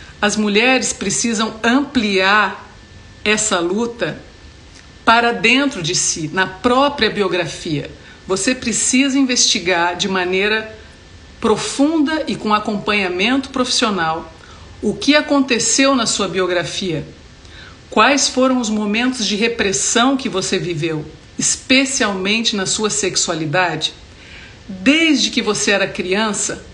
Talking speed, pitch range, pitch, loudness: 105 wpm, 185-245 Hz, 210 Hz, -16 LUFS